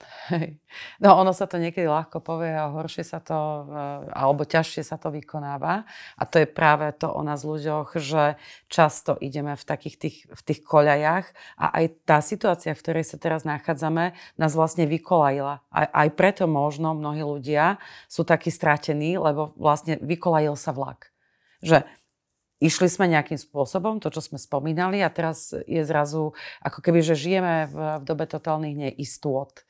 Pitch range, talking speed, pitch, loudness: 150-165 Hz, 160 wpm, 155 Hz, -24 LUFS